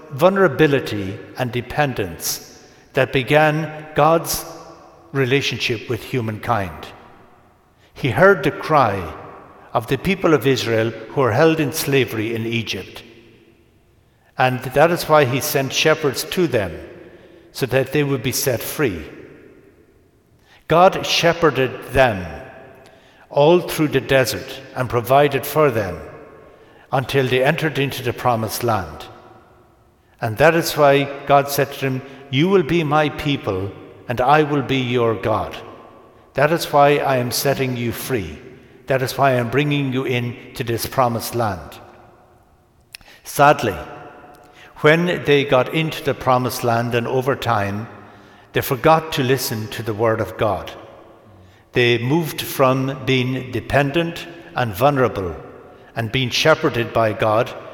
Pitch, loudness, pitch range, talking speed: 130 Hz, -18 LUFS, 115-145 Hz, 130 wpm